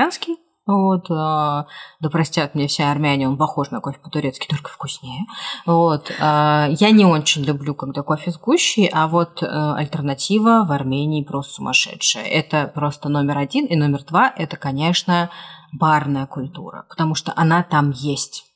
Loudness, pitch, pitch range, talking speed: -19 LUFS, 155 Hz, 145-170 Hz, 145 wpm